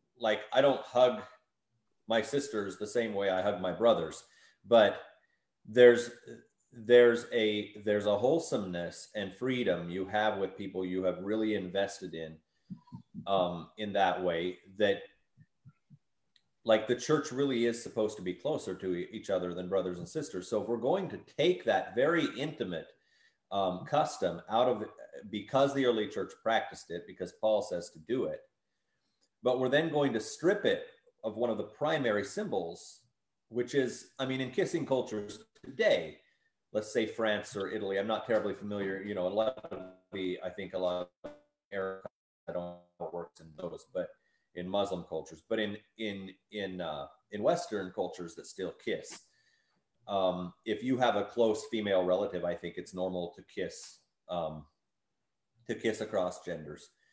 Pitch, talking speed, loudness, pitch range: 105 Hz, 170 wpm, -32 LUFS, 95-120 Hz